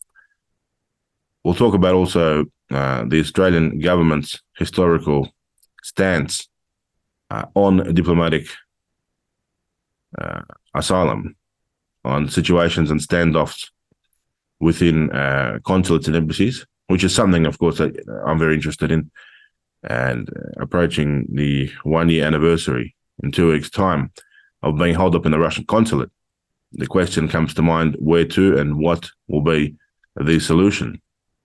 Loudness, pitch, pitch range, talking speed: -18 LUFS, 80 Hz, 75-90 Hz, 120 wpm